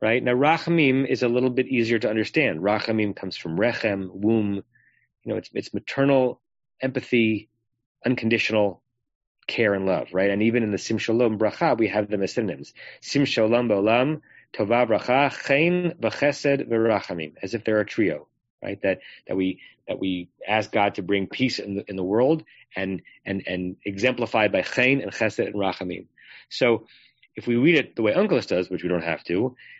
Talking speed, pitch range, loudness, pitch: 180 wpm, 100-125 Hz, -23 LUFS, 110 Hz